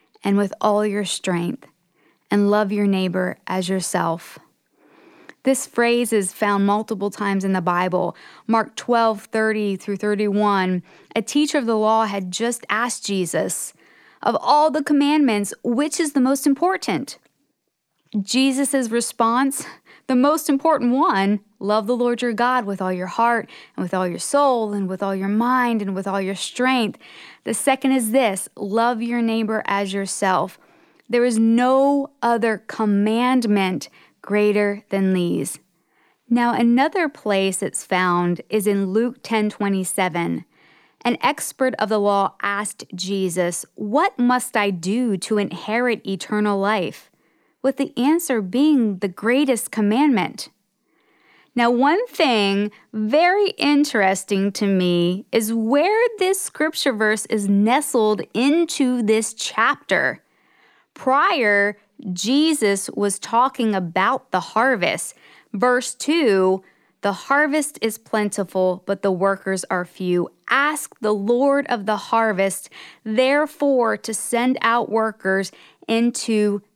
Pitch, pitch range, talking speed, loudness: 220 Hz, 200-255 Hz, 130 wpm, -20 LUFS